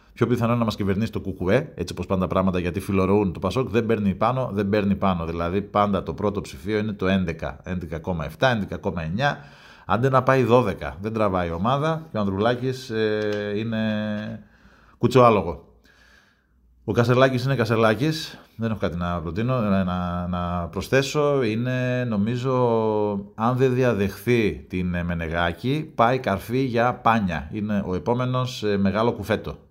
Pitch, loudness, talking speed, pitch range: 105 Hz, -23 LUFS, 145 wpm, 95-120 Hz